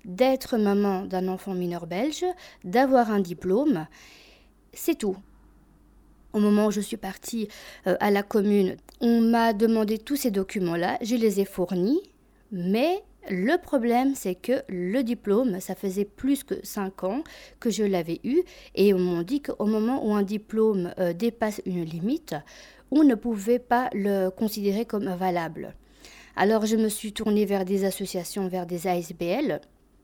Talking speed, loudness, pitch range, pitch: 155 wpm, -26 LUFS, 190-240 Hz, 210 Hz